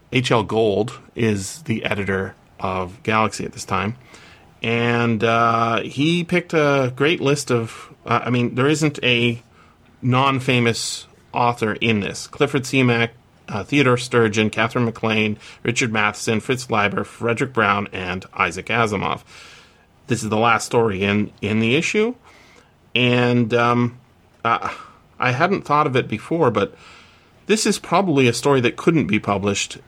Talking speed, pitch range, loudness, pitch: 145 wpm, 105-130 Hz, -20 LUFS, 115 Hz